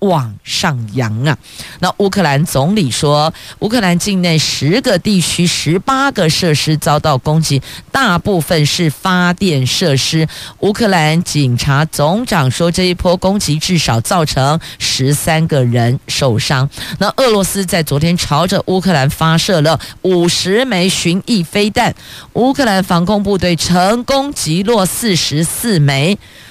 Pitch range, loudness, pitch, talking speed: 150-190 Hz, -13 LUFS, 170 Hz, 220 characters per minute